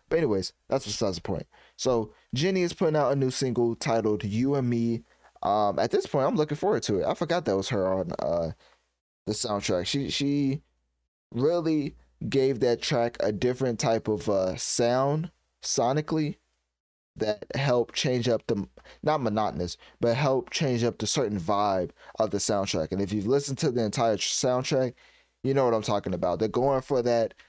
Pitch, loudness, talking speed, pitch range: 120 Hz, -27 LUFS, 185 wpm, 105-140 Hz